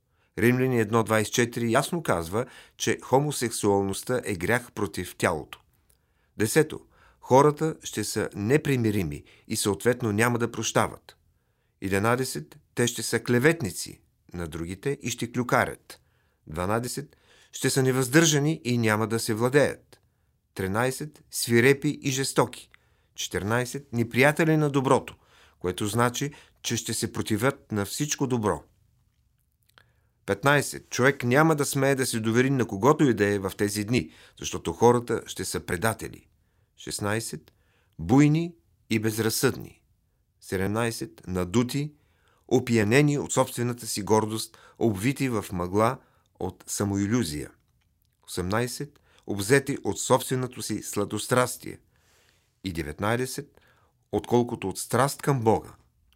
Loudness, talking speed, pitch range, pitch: -26 LUFS, 115 wpm, 105-130 Hz, 115 Hz